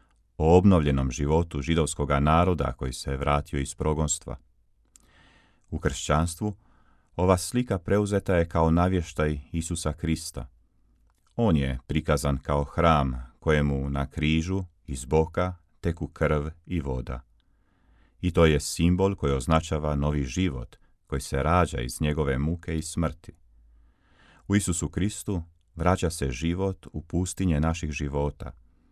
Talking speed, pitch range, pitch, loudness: 125 wpm, 70-90 Hz, 80 Hz, -26 LUFS